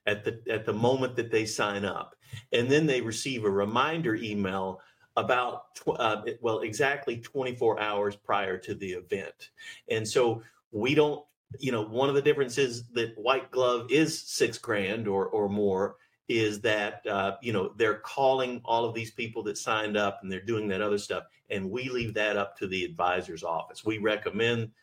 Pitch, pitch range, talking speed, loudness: 115 Hz, 105-130 Hz, 185 wpm, -29 LUFS